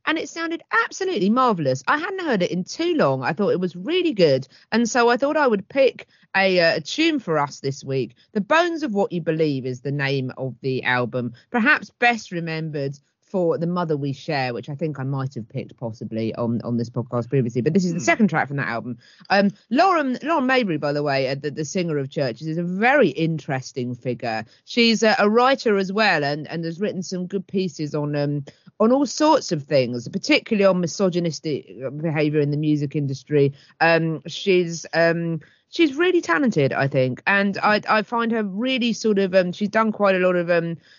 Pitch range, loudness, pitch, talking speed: 140-215 Hz, -21 LUFS, 170 Hz, 210 wpm